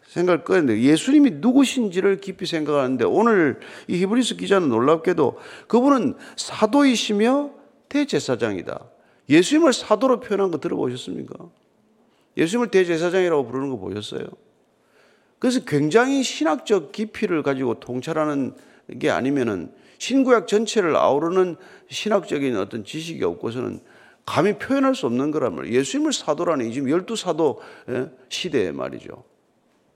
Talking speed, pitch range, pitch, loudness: 335 characters per minute, 165-265 Hz, 210 Hz, -21 LUFS